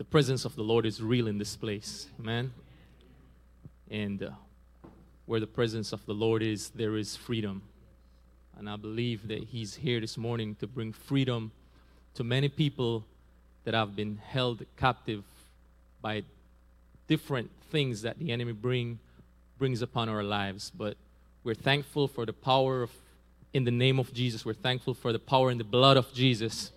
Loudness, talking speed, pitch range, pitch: -31 LUFS, 170 wpm, 100-125 Hz, 110 Hz